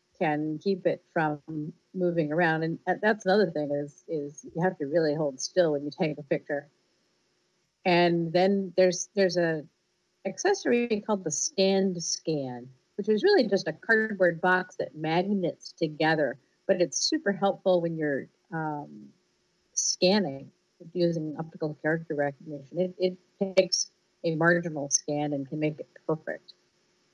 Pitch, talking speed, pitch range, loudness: 170 Hz, 145 wpm, 155-185 Hz, -28 LUFS